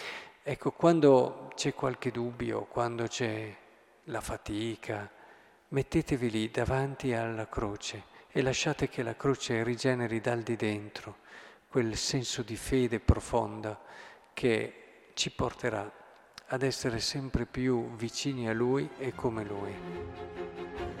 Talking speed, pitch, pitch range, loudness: 115 wpm, 120 Hz, 110-130 Hz, -32 LUFS